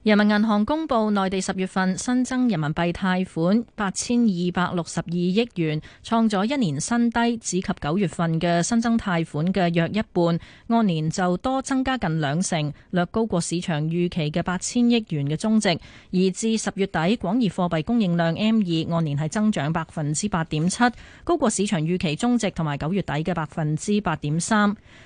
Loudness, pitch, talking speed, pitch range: -23 LUFS, 185 Hz, 275 characters per minute, 165-220 Hz